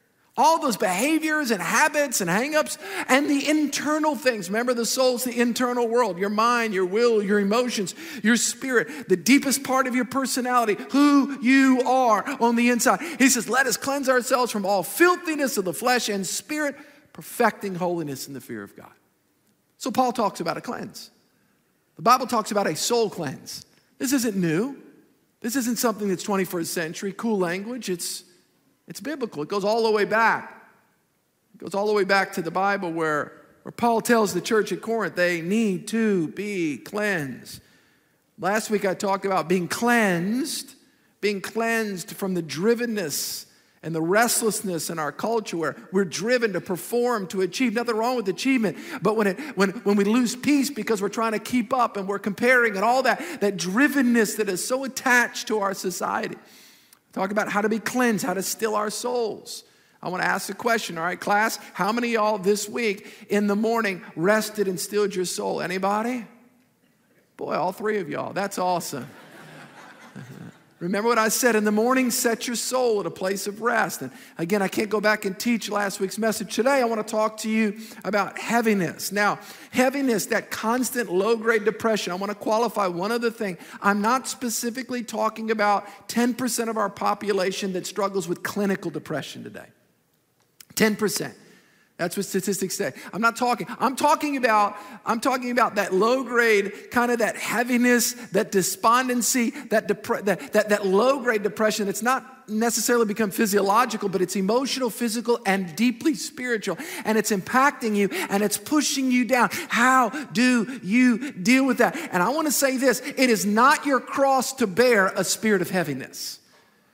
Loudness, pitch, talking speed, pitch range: -23 LUFS, 220 Hz, 180 wpm, 200-245 Hz